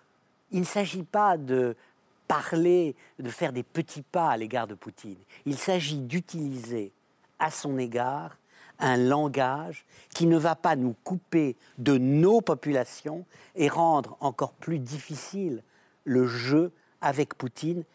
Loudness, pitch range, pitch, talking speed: -28 LUFS, 130-165 Hz, 145 Hz, 135 wpm